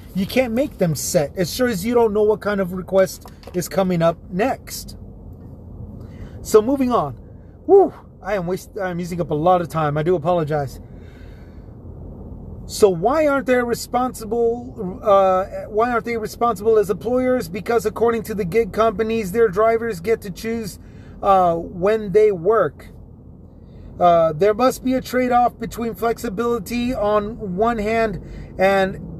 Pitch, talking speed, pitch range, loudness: 205 Hz, 155 wpm, 165-230 Hz, -19 LUFS